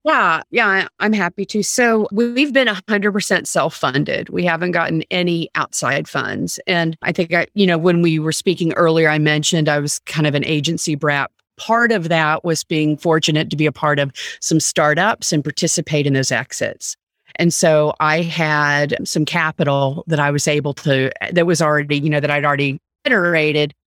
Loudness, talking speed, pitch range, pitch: -17 LUFS, 185 wpm, 150-180 Hz, 160 Hz